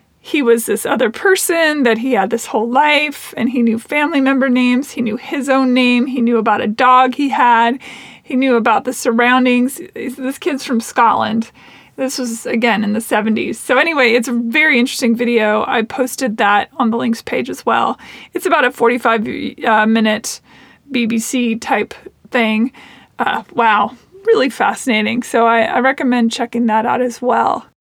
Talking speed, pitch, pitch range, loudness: 175 wpm, 245 Hz, 230-265 Hz, -15 LUFS